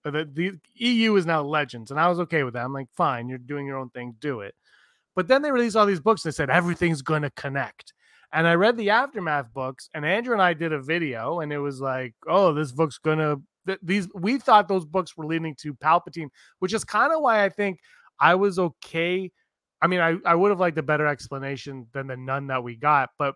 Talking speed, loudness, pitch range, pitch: 240 wpm, -24 LUFS, 140-185 Hz, 160 Hz